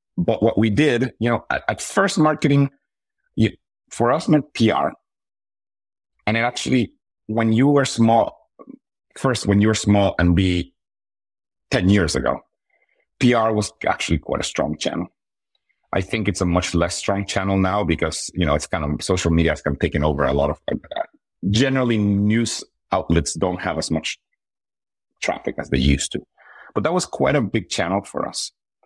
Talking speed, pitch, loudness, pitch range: 180 wpm, 100 Hz, -20 LUFS, 85-115 Hz